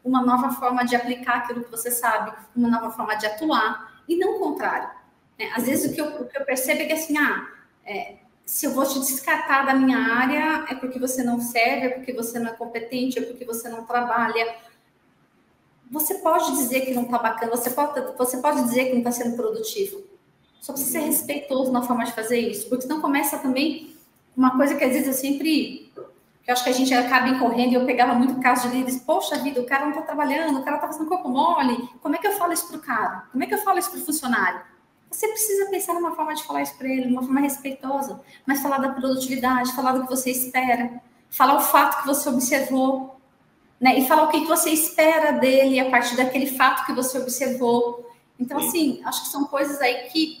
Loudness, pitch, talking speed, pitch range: -22 LUFS, 265 Hz, 230 wpm, 245-295 Hz